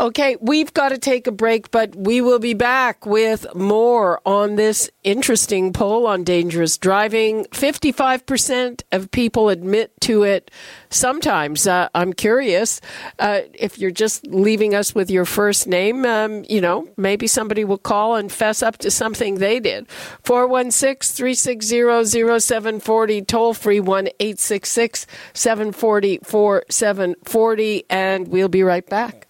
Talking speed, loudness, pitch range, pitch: 140 wpm, -18 LUFS, 195-235 Hz, 215 Hz